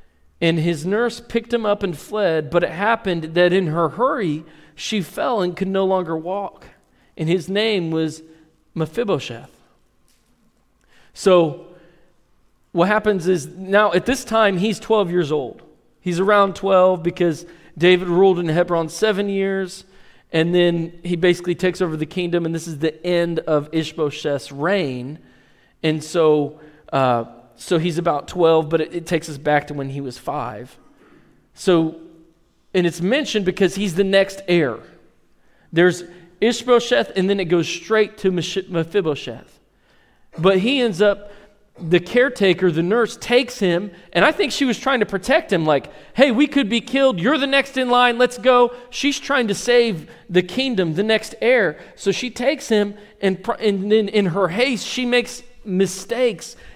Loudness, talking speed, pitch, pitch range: -19 LUFS, 165 wpm, 185 Hz, 170-220 Hz